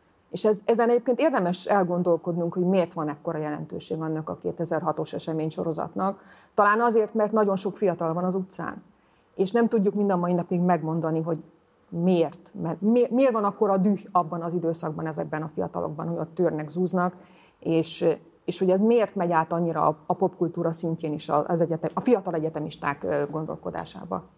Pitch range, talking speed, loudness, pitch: 160-195 Hz, 170 wpm, -26 LUFS, 175 Hz